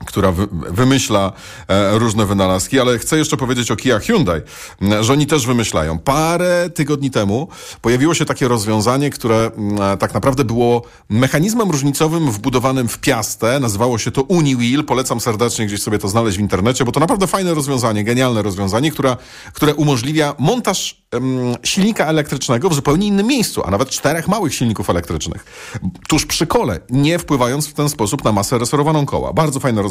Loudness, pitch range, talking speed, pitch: -16 LUFS, 110-150 Hz, 165 wpm, 130 Hz